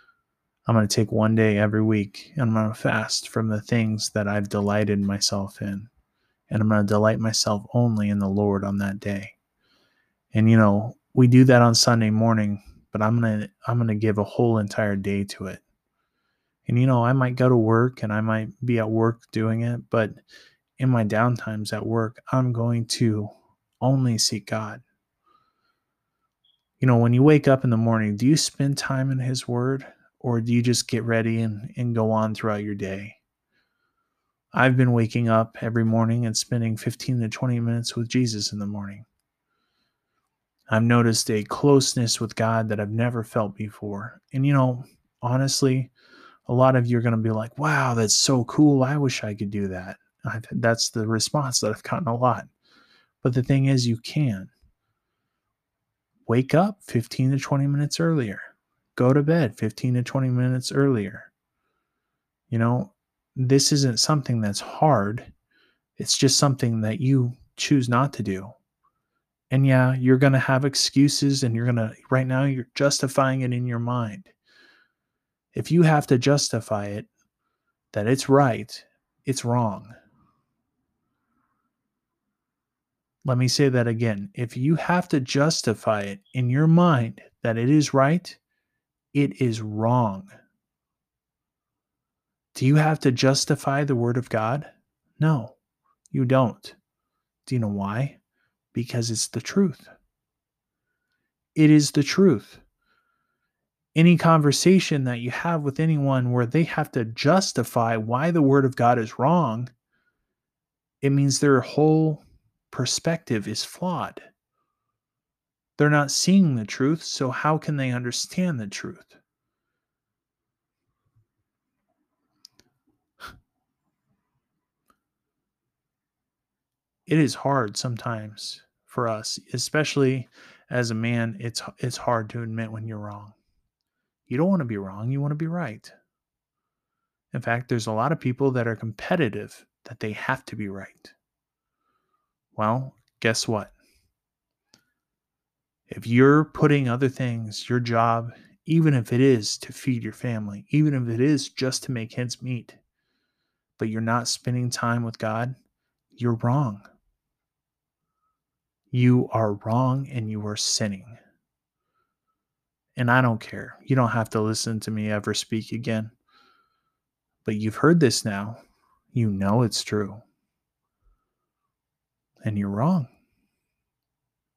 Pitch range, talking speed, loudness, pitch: 110-135 Hz, 150 wpm, -23 LUFS, 120 Hz